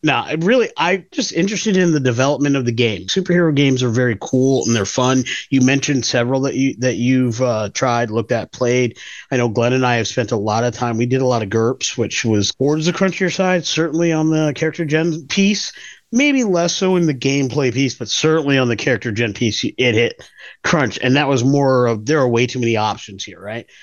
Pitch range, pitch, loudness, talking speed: 120-155 Hz, 130 Hz, -17 LUFS, 225 wpm